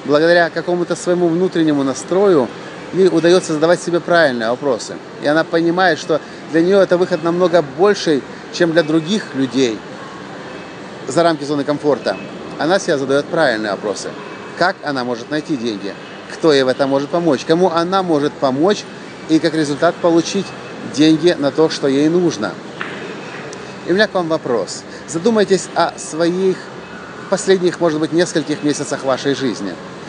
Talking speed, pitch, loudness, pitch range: 150 wpm, 165 Hz, -16 LUFS, 150-180 Hz